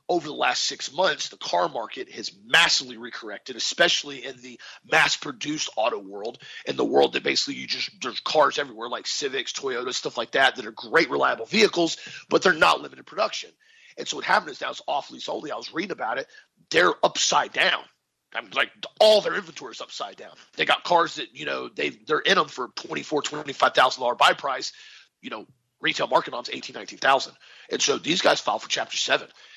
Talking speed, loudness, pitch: 200 wpm, -23 LUFS, 390 Hz